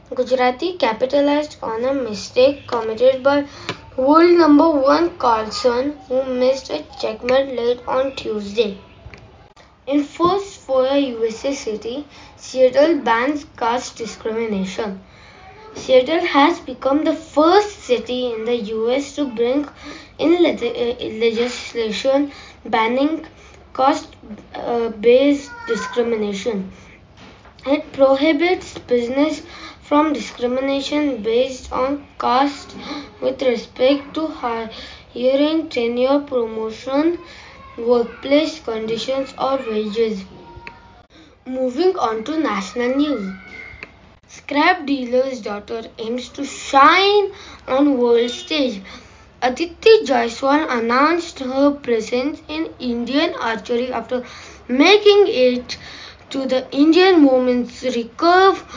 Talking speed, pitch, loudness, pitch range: 95 wpm, 260 Hz, -18 LUFS, 240-290 Hz